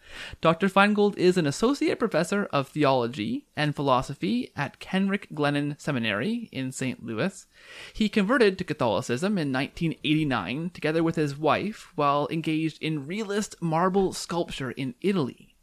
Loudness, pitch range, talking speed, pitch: -26 LUFS, 145-200 Hz, 135 wpm, 165 Hz